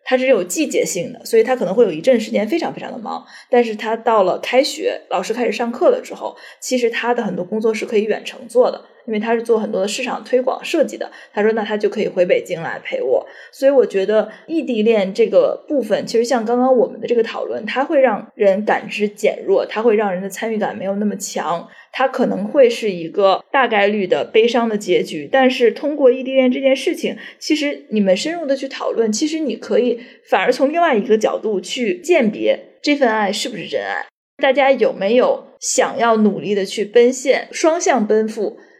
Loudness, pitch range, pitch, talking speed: -17 LUFS, 215-290 Hz, 250 Hz, 320 characters per minute